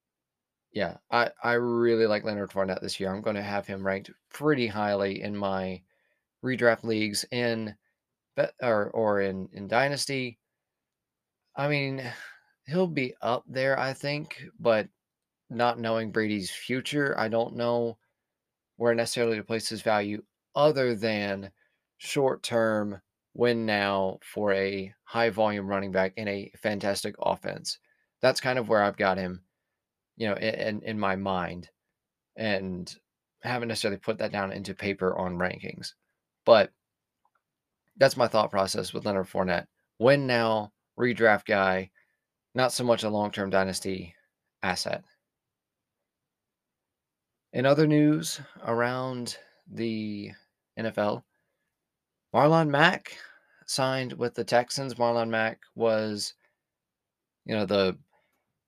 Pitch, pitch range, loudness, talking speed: 110 Hz, 100-120 Hz, -28 LUFS, 130 wpm